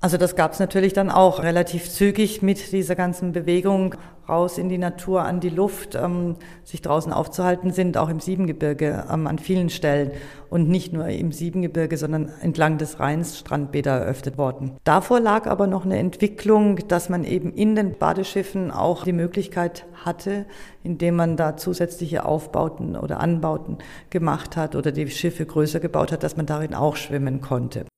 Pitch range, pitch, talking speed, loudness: 155-185 Hz, 175 Hz, 175 wpm, -22 LUFS